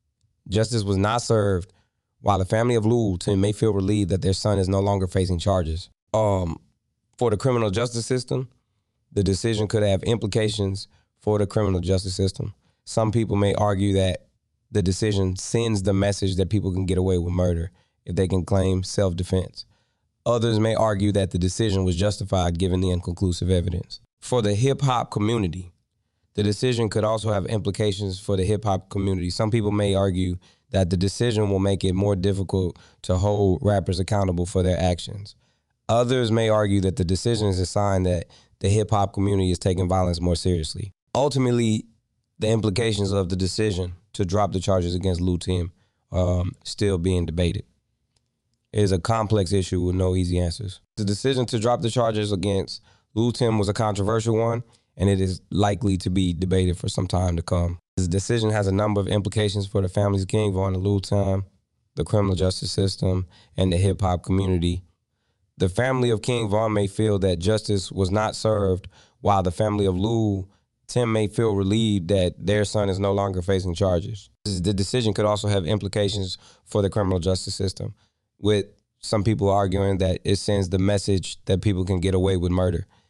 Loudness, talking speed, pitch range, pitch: -23 LUFS, 185 wpm, 95-110 Hz, 100 Hz